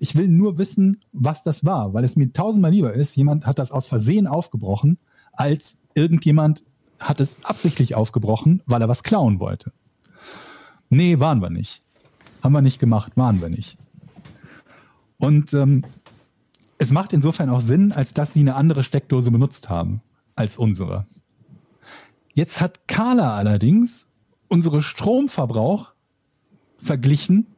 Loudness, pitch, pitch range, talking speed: -19 LUFS, 145 Hz, 120-165 Hz, 140 wpm